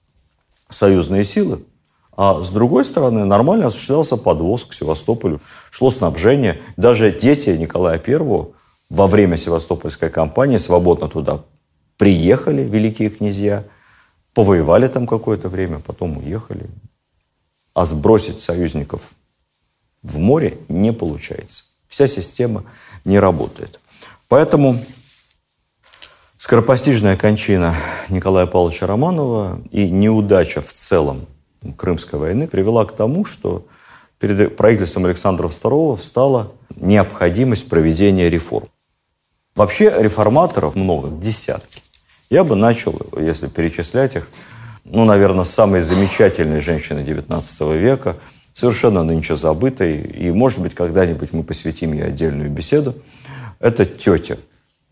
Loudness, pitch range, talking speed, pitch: -16 LUFS, 85-115 Hz, 105 wpm, 100 Hz